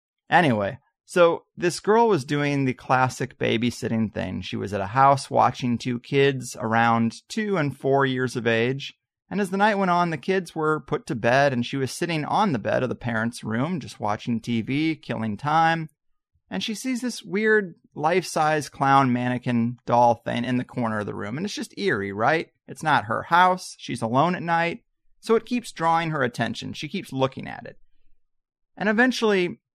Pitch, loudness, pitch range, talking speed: 135 Hz, -23 LUFS, 120-175 Hz, 195 wpm